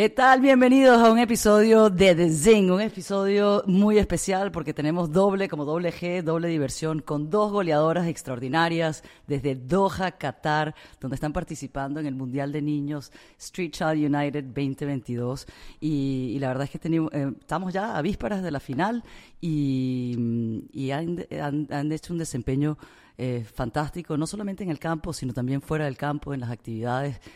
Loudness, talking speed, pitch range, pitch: -24 LUFS, 170 wpm, 140-185 Hz, 155 Hz